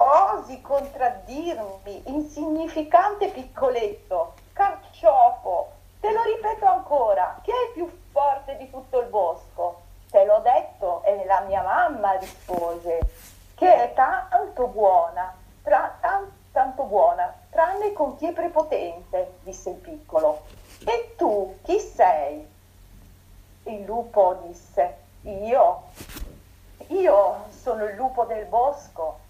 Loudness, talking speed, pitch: -23 LUFS, 115 wpm, 265 Hz